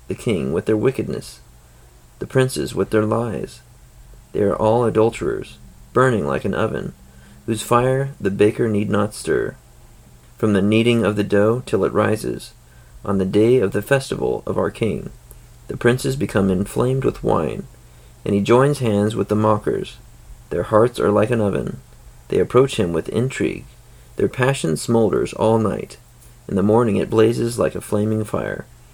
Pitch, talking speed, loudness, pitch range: 110 Hz, 170 wpm, -19 LUFS, 95-120 Hz